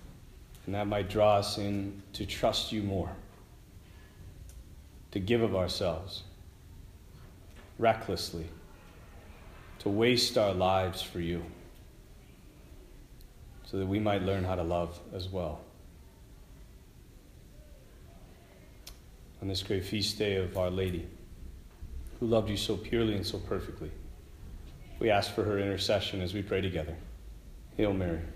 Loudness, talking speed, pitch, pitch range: -32 LUFS, 125 wpm, 95 Hz, 85-100 Hz